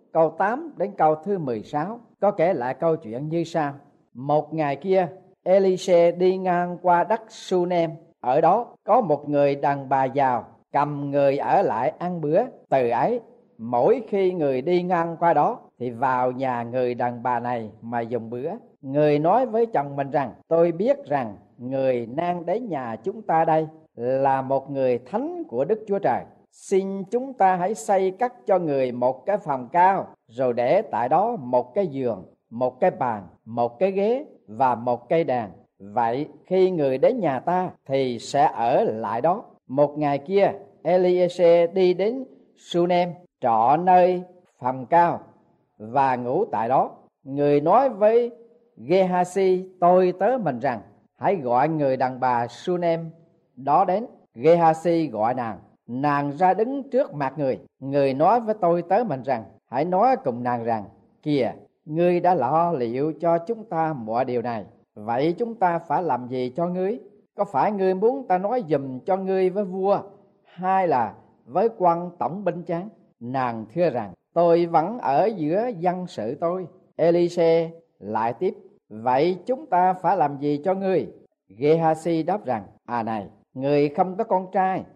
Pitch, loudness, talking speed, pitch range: 170 Hz, -23 LUFS, 170 wpm, 135-185 Hz